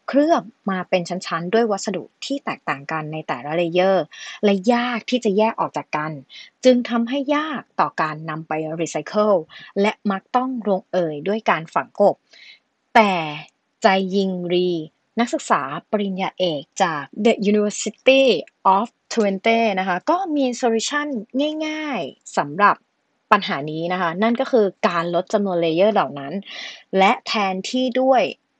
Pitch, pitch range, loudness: 205 Hz, 180-245 Hz, -20 LUFS